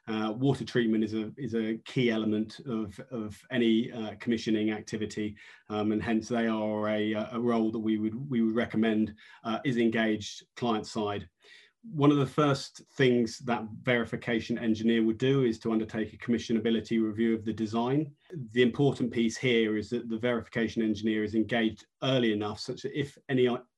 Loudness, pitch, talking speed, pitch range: -30 LUFS, 115 Hz, 175 wpm, 110-120 Hz